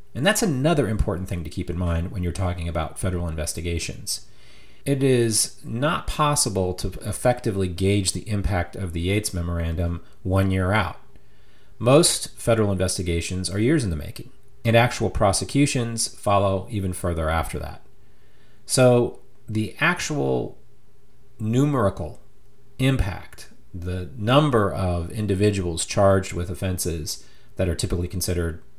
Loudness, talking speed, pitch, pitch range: -23 LUFS, 130 wpm, 100 Hz, 90-120 Hz